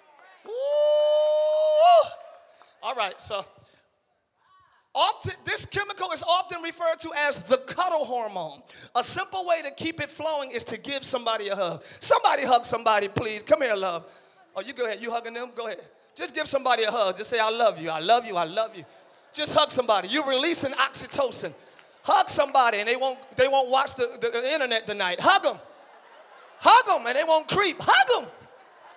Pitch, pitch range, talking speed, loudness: 290 Hz, 235-335 Hz, 185 wpm, -24 LUFS